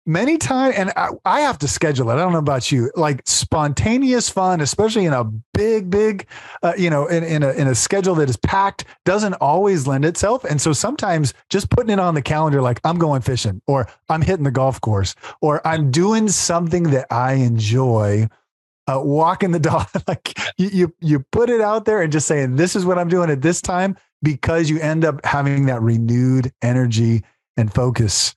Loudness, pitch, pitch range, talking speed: -18 LUFS, 155 Hz, 130-180 Hz, 205 wpm